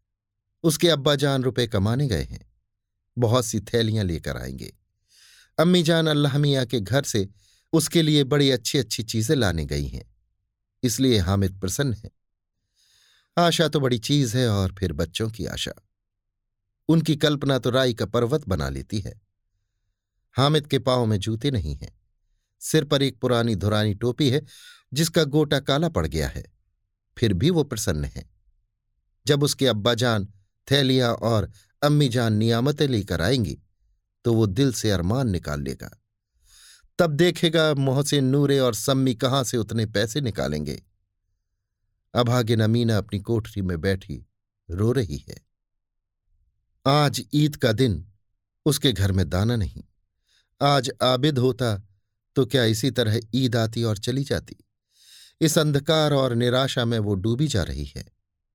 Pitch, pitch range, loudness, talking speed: 115 Hz, 100-135 Hz, -23 LUFS, 145 wpm